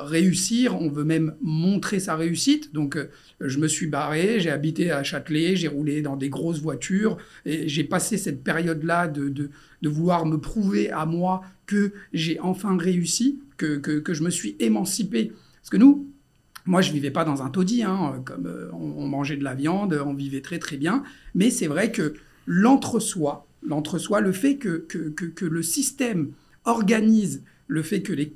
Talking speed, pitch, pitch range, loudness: 190 wpm, 165 Hz, 150-190 Hz, -24 LUFS